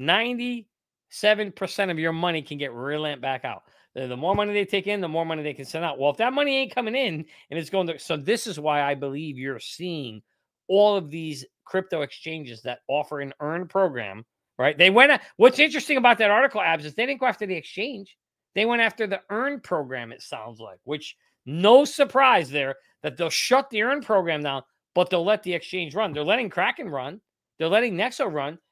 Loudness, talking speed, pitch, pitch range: -23 LUFS, 210 wpm, 175 Hz, 150-215 Hz